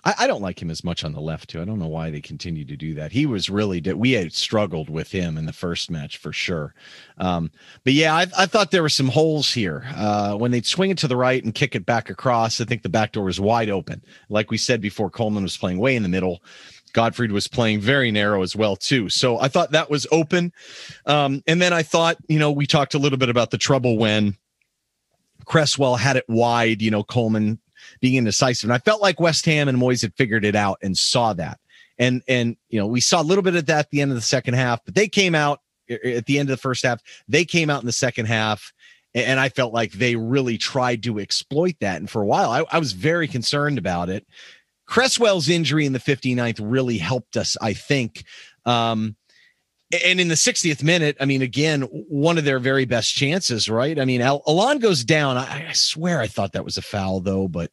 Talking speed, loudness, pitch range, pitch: 240 wpm, -20 LUFS, 105-150 Hz, 125 Hz